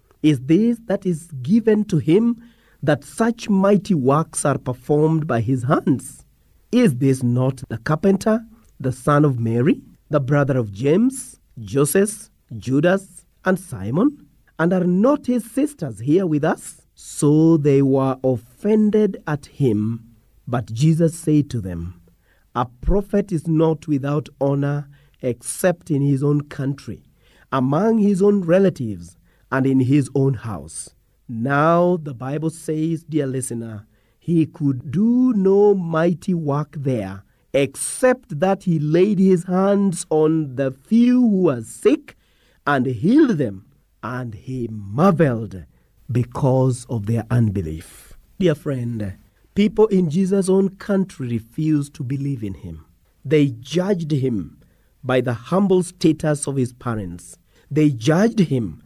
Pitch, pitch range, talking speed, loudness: 145 Hz, 125-185 Hz, 135 wpm, -20 LUFS